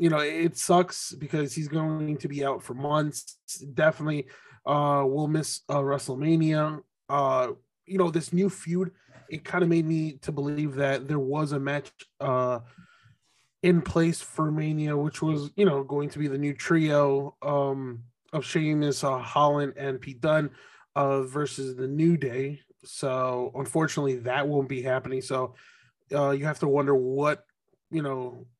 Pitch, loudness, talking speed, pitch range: 145 Hz, -27 LUFS, 165 wpm, 135-155 Hz